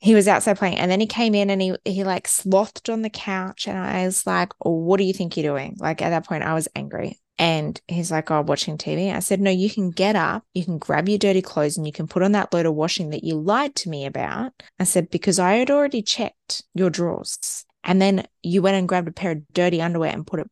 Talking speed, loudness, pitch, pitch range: 270 wpm, -22 LUFS, 185 Hz, 165-200 Hz